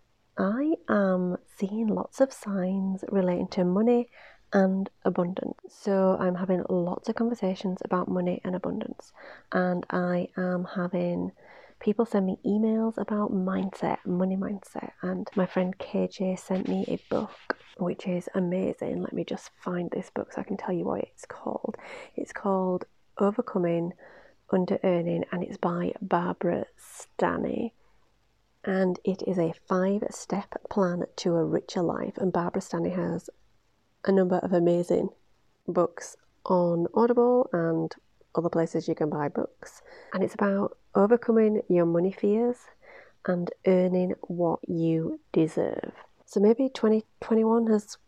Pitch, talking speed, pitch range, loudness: 190 Hz, 140 wpm, 180-215 Hz, -28 LUFS